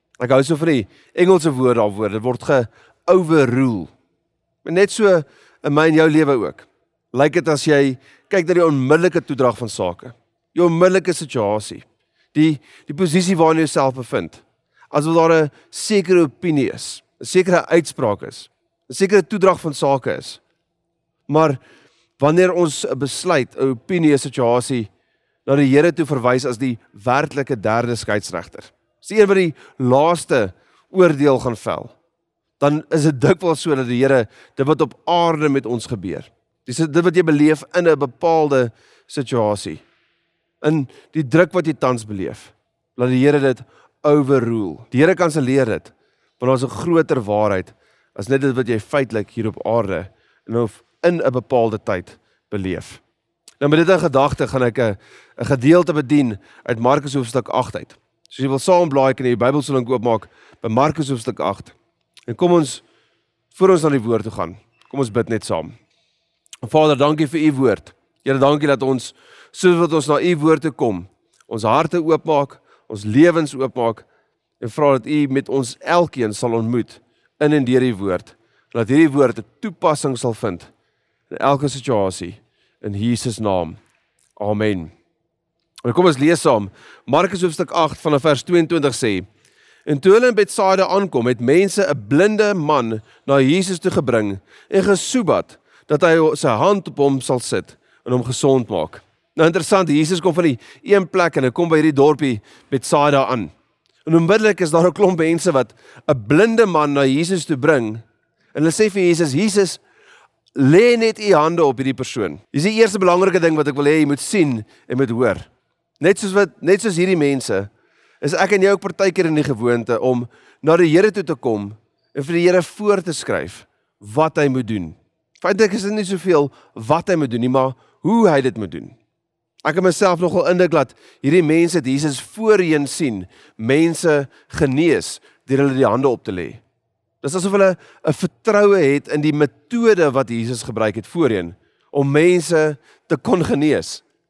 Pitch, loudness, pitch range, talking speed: 145 Hz, -17 LUFS, 125-170 Hz, 180 wpm